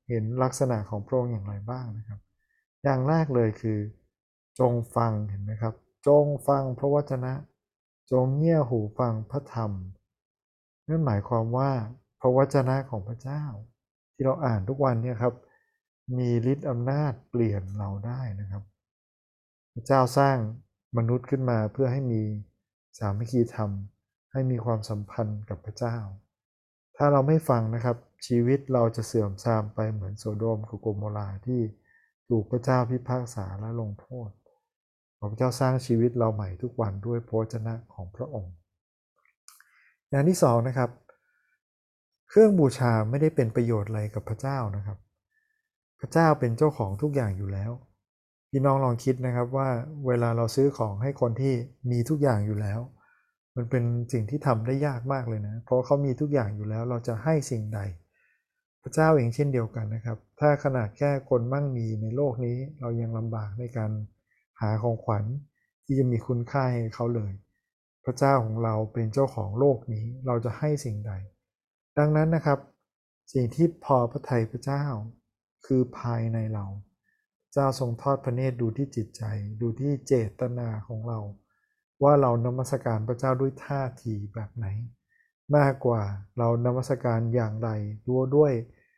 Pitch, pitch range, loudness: 120 Hz, 110-135 Hz, -27 LUFS